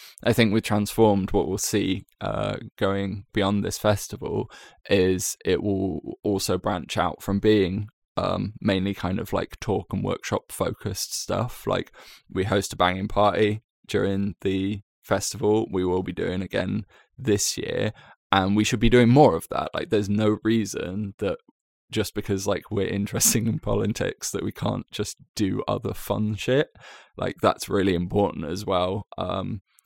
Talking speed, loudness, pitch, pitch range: 165 wpm, -25 LUFS, 100 Hz, 95-105 Hz